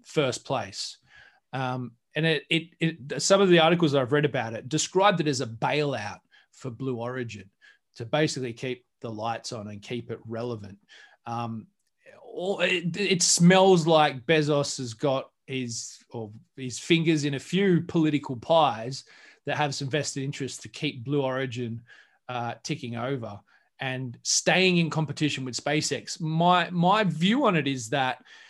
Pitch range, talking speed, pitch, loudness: 125-165 Hz, 160 wpm, 140 Hz, -26 LUFS